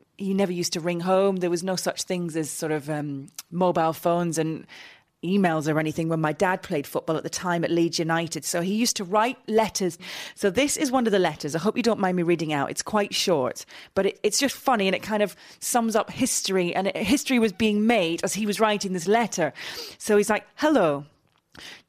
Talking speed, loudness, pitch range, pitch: 230 wpm, -24 LUFS, 165-215 Hz, 185 Hz